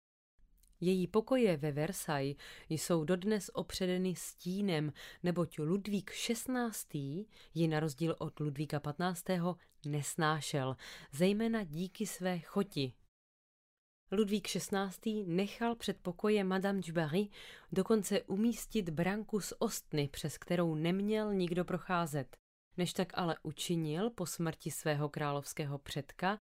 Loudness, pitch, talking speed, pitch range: -36 LUFS, 175 Hz, 110 wpm, 155-200 Hz